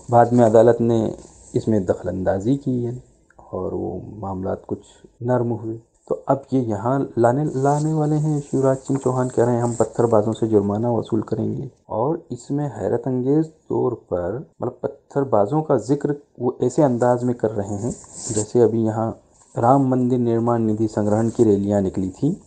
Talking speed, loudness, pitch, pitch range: 165 wpm, -21 LUFS, 120 Hz, 110-135 Hz